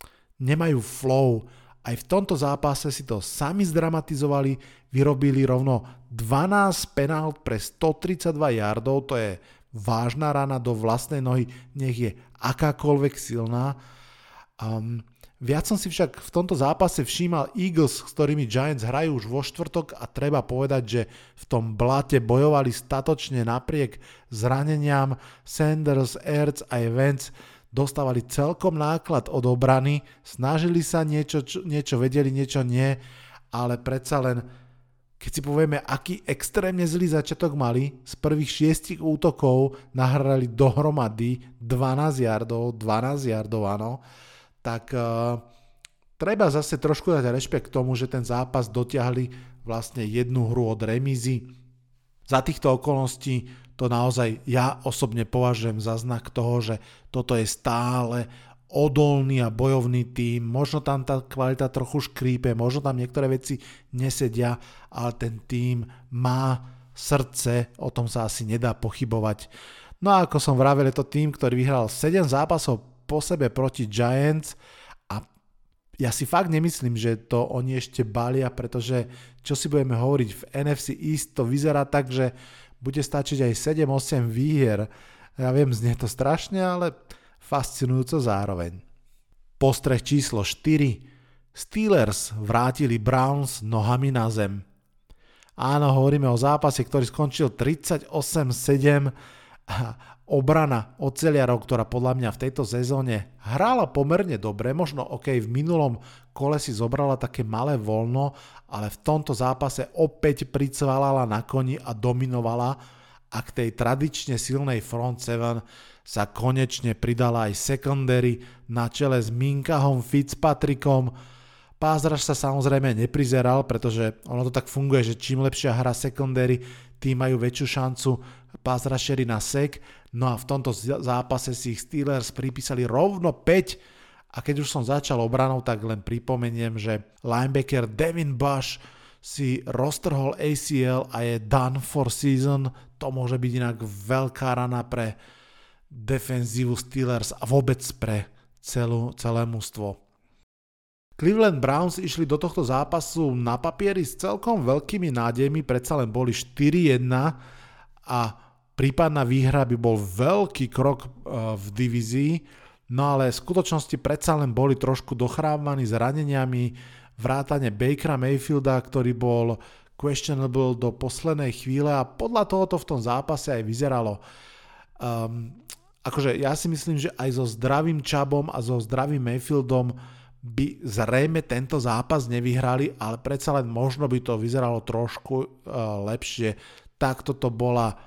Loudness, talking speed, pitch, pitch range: -25 LUFS, 135 wpm, 130 Hz, 120-145 Hz